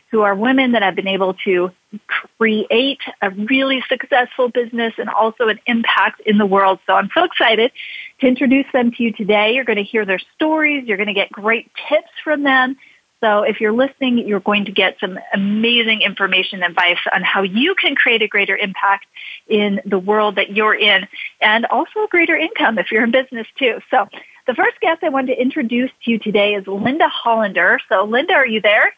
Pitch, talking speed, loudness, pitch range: 225 Hz, 205 wpm, -16 LUFS, 205-265 Hz